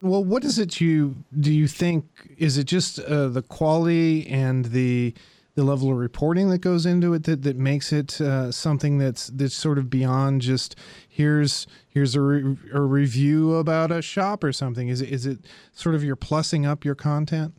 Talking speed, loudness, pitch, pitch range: 200 wpm, -23 LUFS, 145 Hz, 135-160 Hz